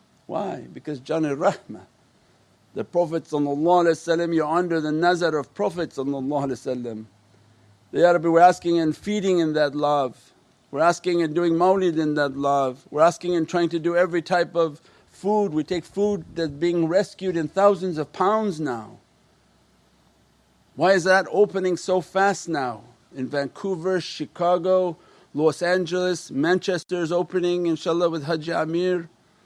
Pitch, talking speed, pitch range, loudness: 170 Hz, 145 wpm, 150-180 Hz, -23 LUFS